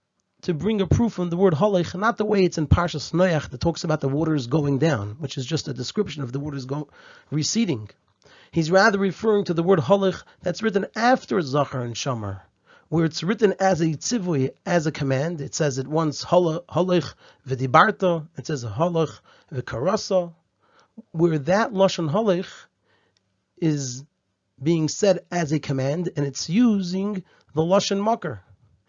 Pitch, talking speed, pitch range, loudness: 165 Hz, 165 wpm, 140-190 Hz, -23 LUFS